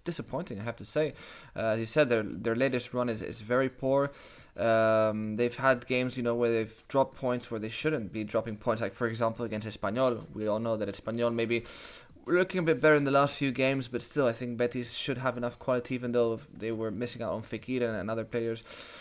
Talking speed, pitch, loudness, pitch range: 235 wpm, 120 Hz, -30 LUFS, 110-130 Hz